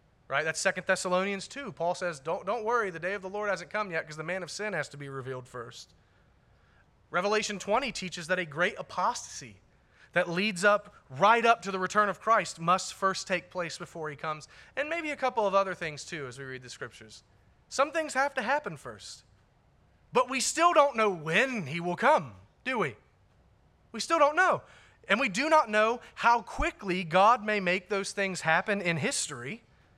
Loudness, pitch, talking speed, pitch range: -29 LUFS, 190 Hz, 200 wpm, 170-230 Hz